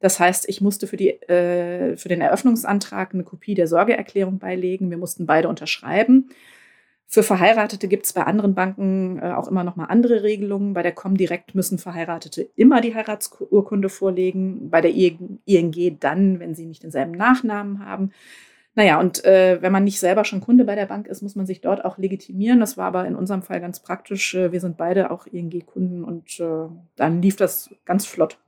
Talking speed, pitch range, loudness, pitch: 190 wpm, 175-205 Hz, -20 LUFS, 190 Hz